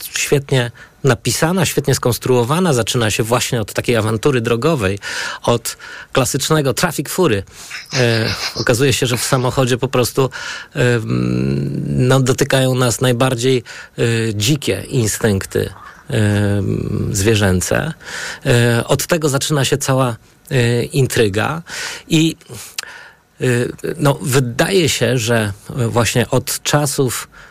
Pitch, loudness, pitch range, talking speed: 125 Hz, -16 LUFS, 115-140 Hz, 110 wpm